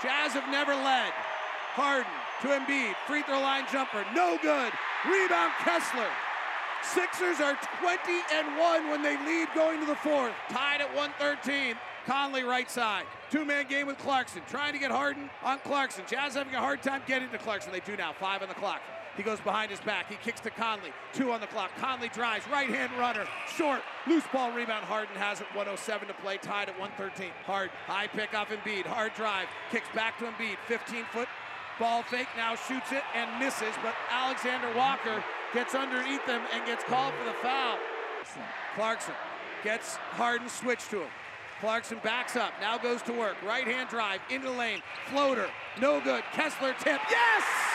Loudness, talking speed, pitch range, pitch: -31 LUFS, 180 wpm, 220-280 Hz, 250 Hz